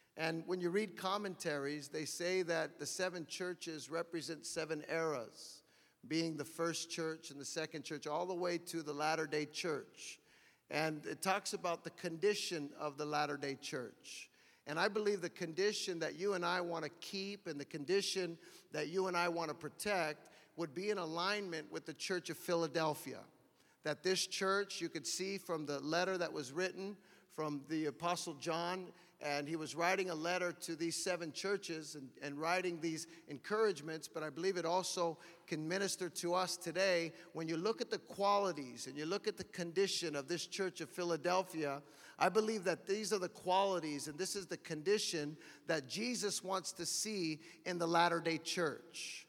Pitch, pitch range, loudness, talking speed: 170 Hz, 160-185 Hz, -39 LUFS, 185 wpm